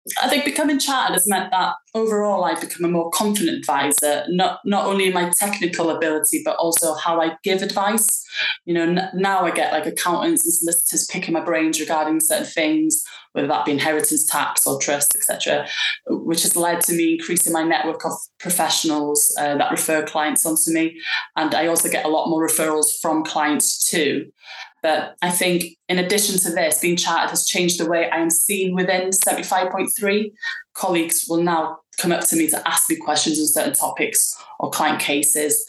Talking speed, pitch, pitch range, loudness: 190 wpm, 170 Hz, 160-195 Hz, -19 LUFS